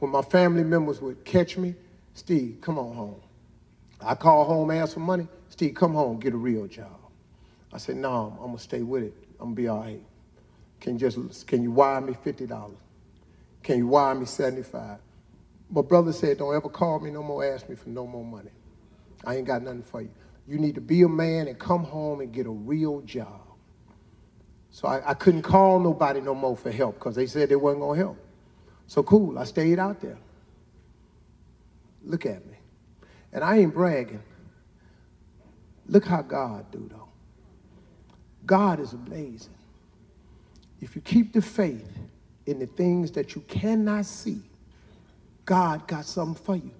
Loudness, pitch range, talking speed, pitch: -25 LUFS, 120-175 Hz, 185 wpm, 145 Hz